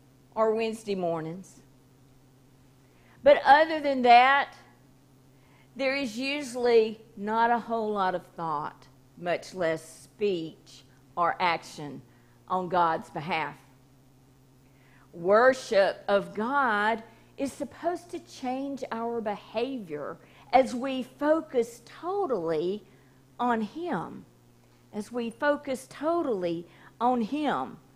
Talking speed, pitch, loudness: 95 wpm, 200 Hz, -27 LUFS